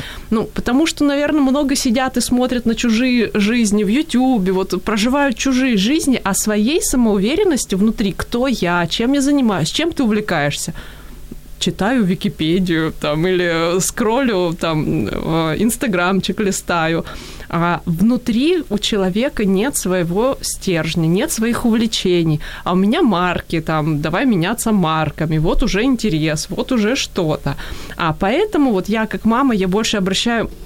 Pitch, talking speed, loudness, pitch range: 210 Hz, 135 wpm, -17 LUFS, 180-250 Hz